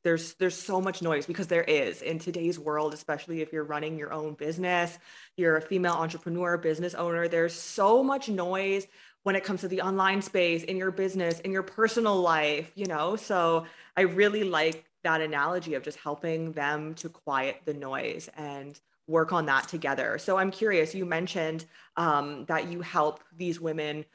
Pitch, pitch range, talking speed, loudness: 170 Hz, 155-185 Hz, 185 wpm, -29 LUFS